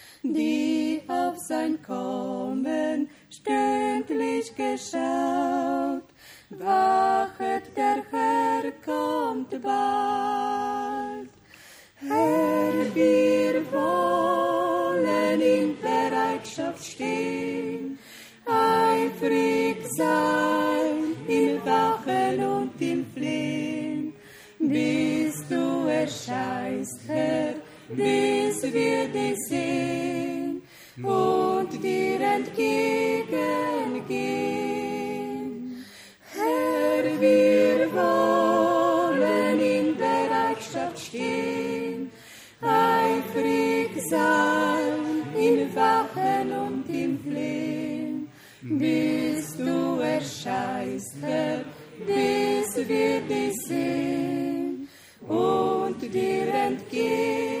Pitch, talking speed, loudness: 100 Hz, 65 wpm, -25 LUFS